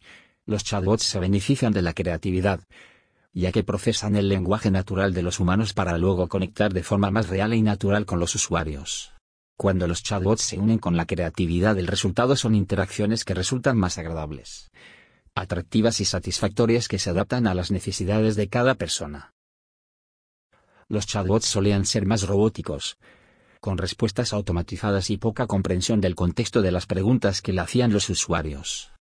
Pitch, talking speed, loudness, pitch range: 100 Hz, 160 wpm, -24 LUFS, 90-110 Hz